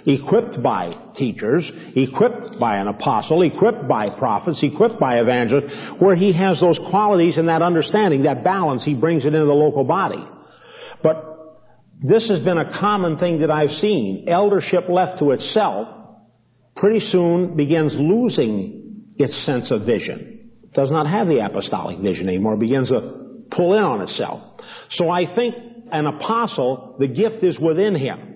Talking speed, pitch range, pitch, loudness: 165 wpm, 150-205 Hz, 170 Hz, -19 LUFS